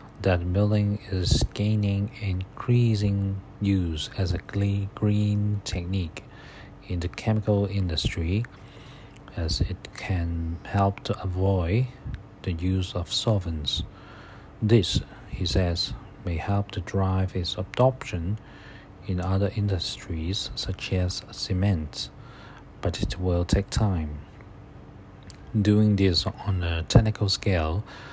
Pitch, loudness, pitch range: 100 Hz, -26 LUFS, 90-105 Hz